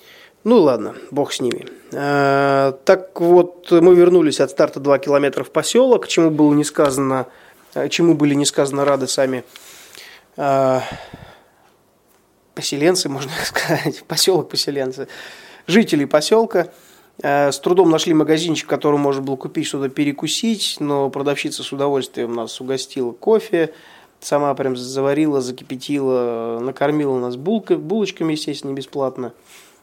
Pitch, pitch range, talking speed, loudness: 145 Hz, 135-170 Hz, 115 wpm, -18 LUFS